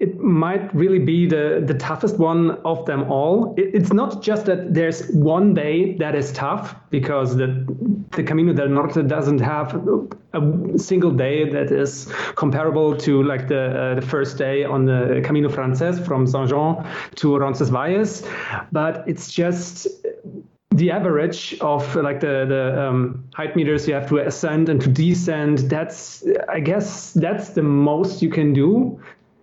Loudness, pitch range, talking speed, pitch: -20 LUFS, 140-180 Hz, 160 wpm, 155 Hz